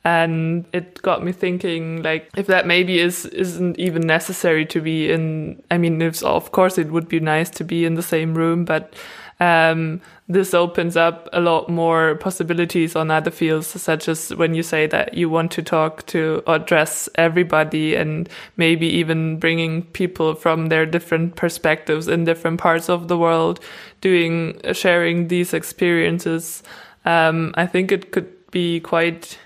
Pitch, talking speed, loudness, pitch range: 165 Hz, 170 wpm, -19 LUFS, 160-175 Hz